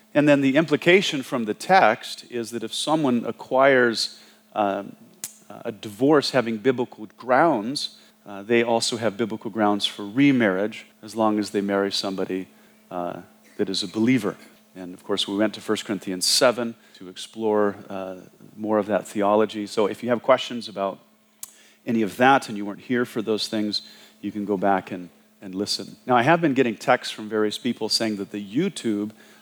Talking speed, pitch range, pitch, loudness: 180 wpm, 100-120 Hz, 110 Hz, -23 LUFS